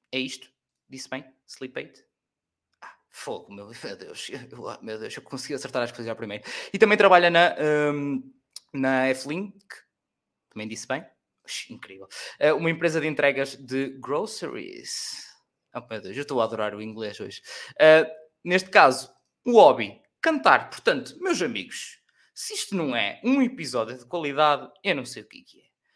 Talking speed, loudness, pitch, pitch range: 165 wpm, -23 LUFS, 145 Hz, 130-195 Hz